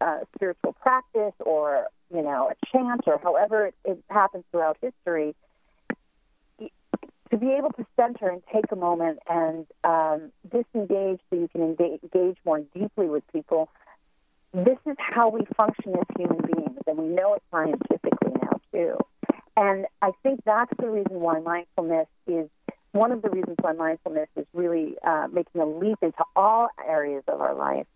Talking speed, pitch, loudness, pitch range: 165 wpm, 185 Hz, -26 LUFS, 165-225 Hz